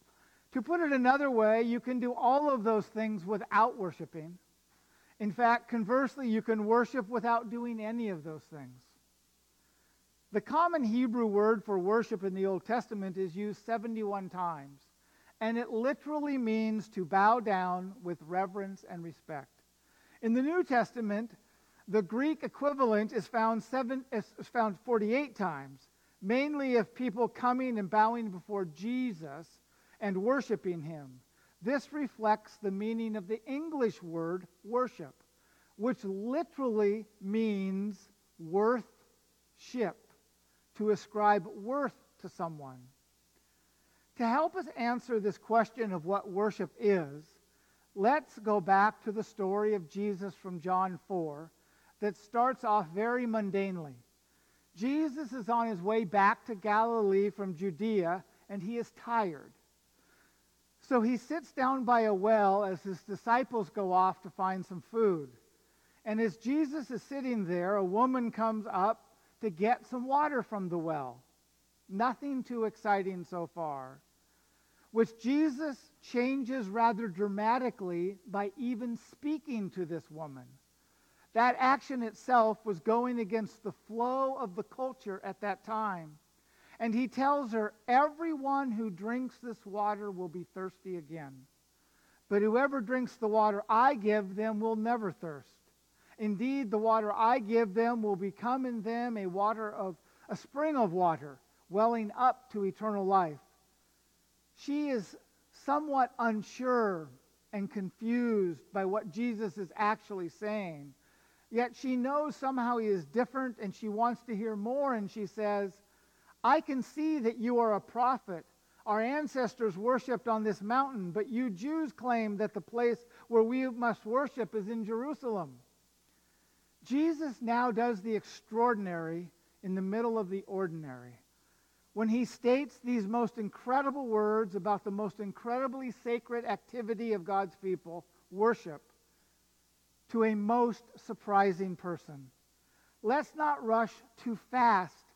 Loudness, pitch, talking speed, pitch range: -33 LUFS, 215 Hz, 140 wpm, 190-240 Hz